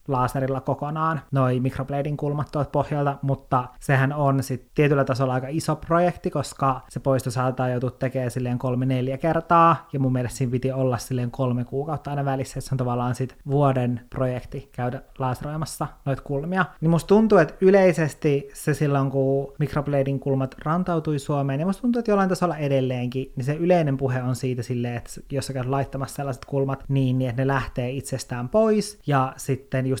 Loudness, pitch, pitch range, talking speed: -24 LUFS, 135 Hz, 130-150 Hz, 180 wpm